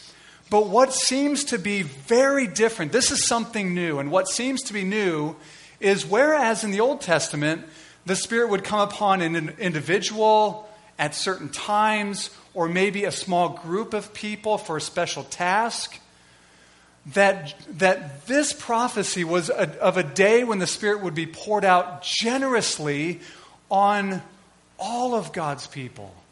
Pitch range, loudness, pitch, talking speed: 165-215 Hz, -23 LUFS, 195 Hz, 150 wpm